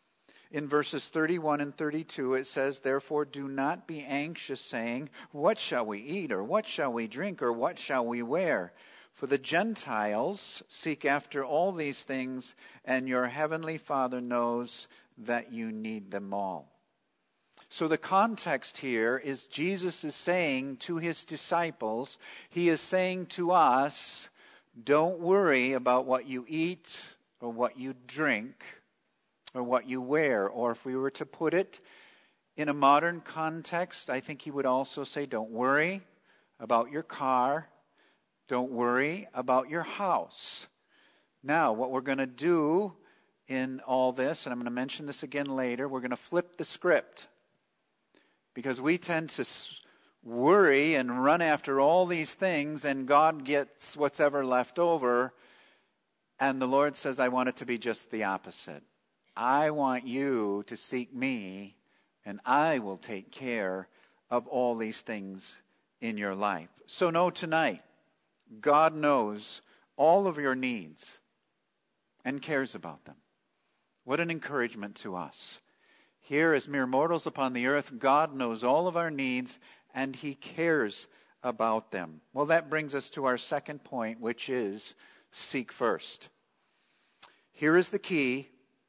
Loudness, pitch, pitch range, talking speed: -30 LUFS, 135 Hz, 125-155 Hz, 150 wpm